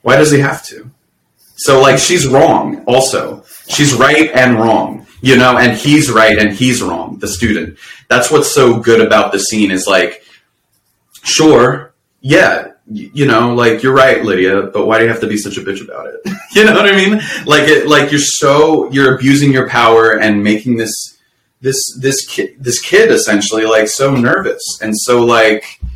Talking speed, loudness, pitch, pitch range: 190 wpm, -10 LUFS, 125 Hz, 110-145 Hz